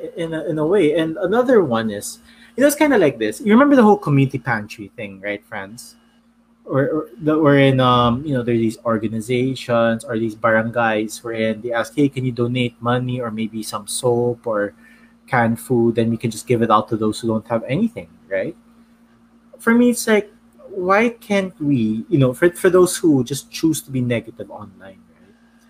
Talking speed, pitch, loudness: 205 wpm, 130 Hz, -18 LUFS